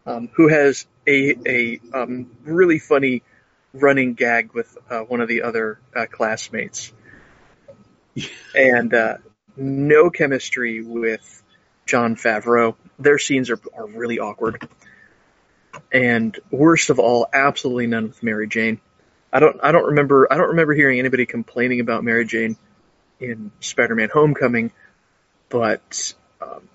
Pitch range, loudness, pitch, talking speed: 115-140 Hz, -18 LUFS, 120 Hz, 135 wpm